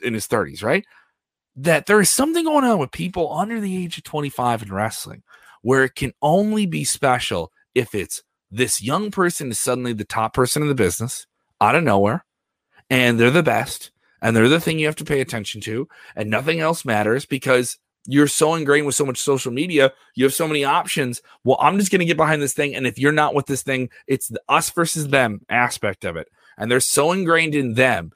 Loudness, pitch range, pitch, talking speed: -19 LUFS, 125-160 Hz, 140 Hz, 220 wpm